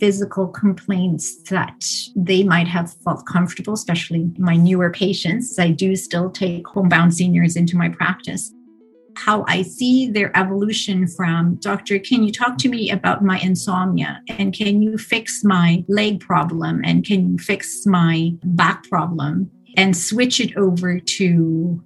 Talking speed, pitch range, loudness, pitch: 150 wpm, 175-205 Hz, -18 LUFS, 185 Hz